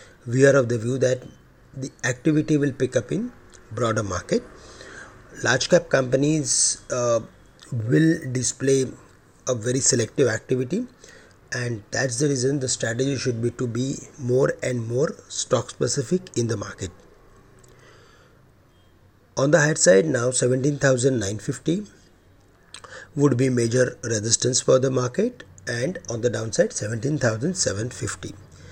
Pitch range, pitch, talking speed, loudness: 115-135 Hz, 125 Hz, 125 wpm, -22 LUFS